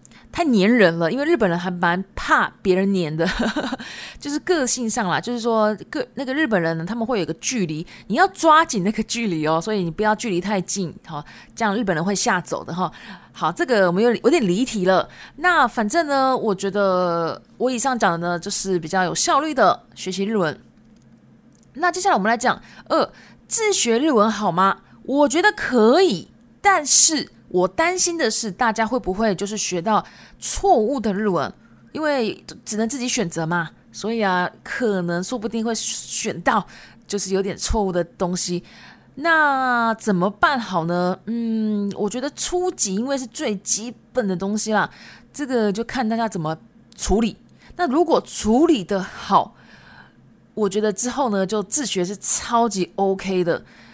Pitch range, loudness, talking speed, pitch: 190-255 Hz, -20 LUFS, 260 characters per minute, 215 Hz